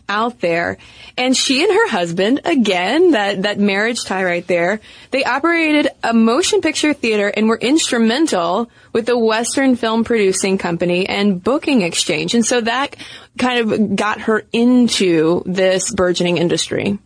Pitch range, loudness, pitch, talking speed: 190-255 Hz, -16 LUFS, 225 Hz, 150 wpm